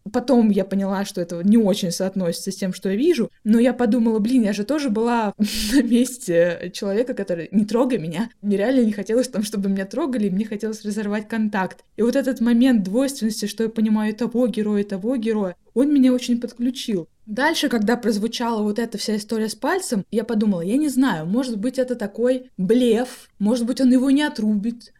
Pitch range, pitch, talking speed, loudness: 205-245 Hz, 225 Hz, 195 wpm, -21 LUFS